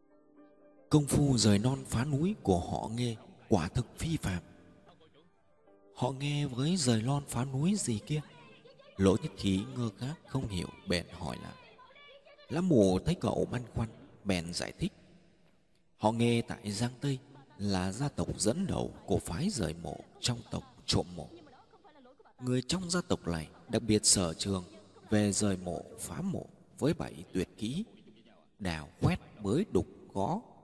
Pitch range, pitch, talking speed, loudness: 95-140 Hz, 115 Hz, 160 wpm, -33 LUFS